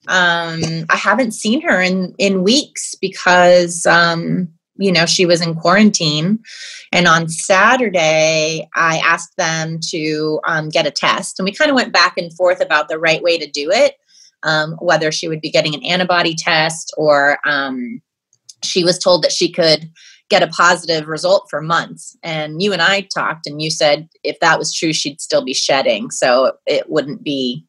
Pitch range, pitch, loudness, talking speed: 160-195 Hz, 175 Hz, -15 LUFS, 185 wpm